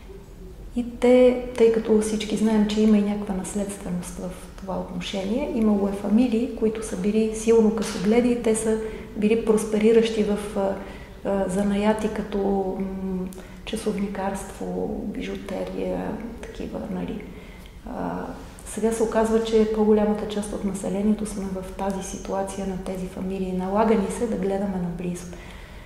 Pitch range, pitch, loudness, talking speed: 190-220 Hz, 210 Hz, -24 LUFS, 135 wpm